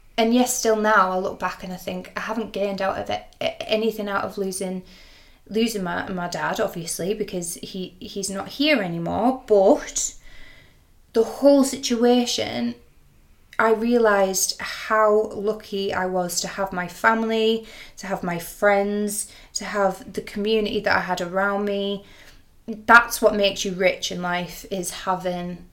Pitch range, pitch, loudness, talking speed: 185-220 Hz, 200 Hz, -22 LUFS, 155 wpm